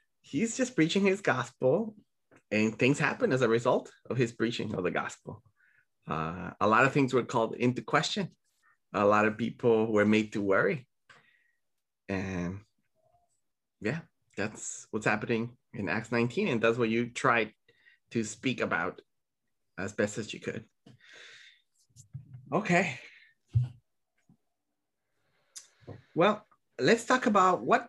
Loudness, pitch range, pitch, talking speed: -29 LUFS, 110-165 Hz, 120 Hz, 130 wpm